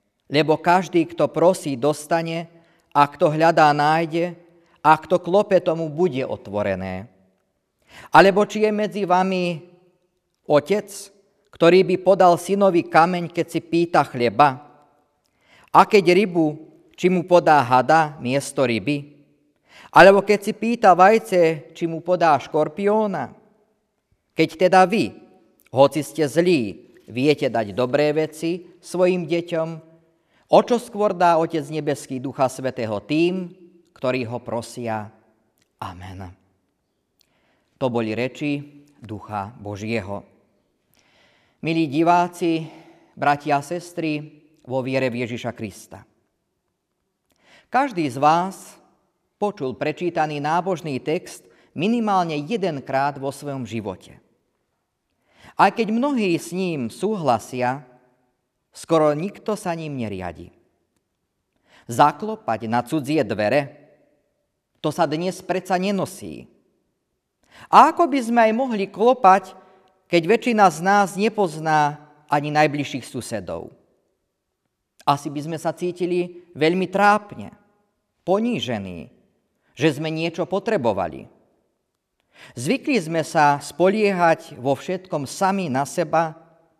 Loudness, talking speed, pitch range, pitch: -20 LUFS, 105 wpm, 140-185 Hz, 160 Hz